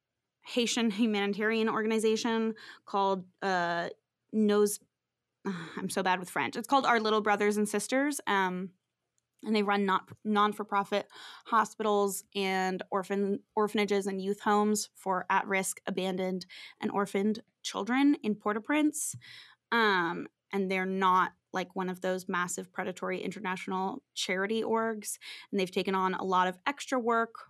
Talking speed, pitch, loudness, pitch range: 135 wpm, 205 Hz, -30 LUFS, 190-220 Hz